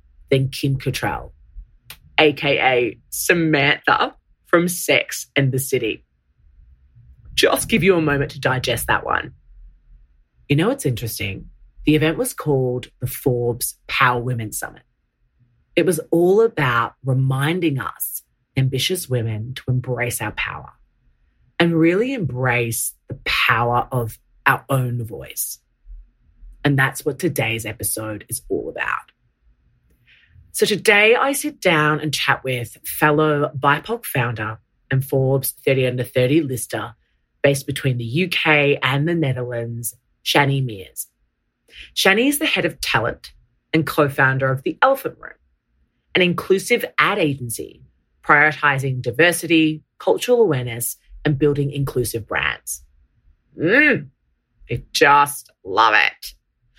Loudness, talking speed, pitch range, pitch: -19 LUFS, 125 wpm, 115-155 Hz, 135 Hz